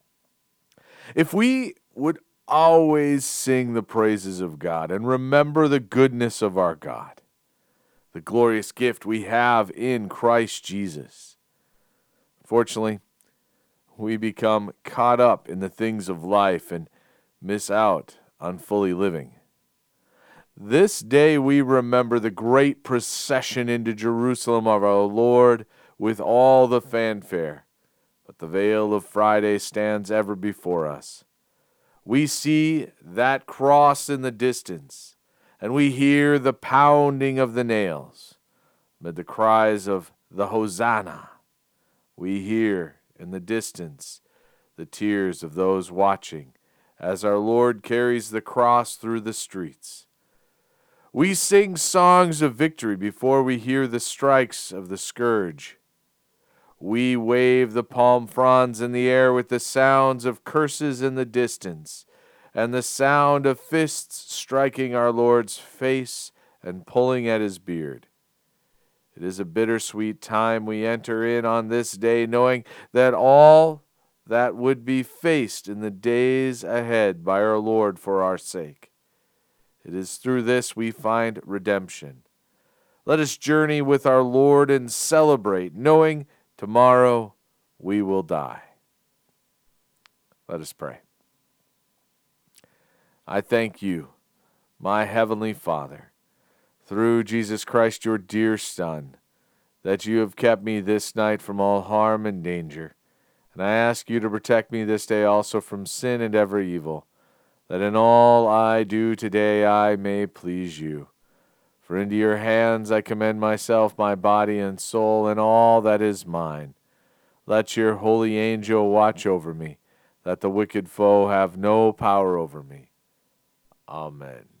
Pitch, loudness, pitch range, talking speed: 110 Hz, -21 LUFS, 100-125 Hz, 135 wpm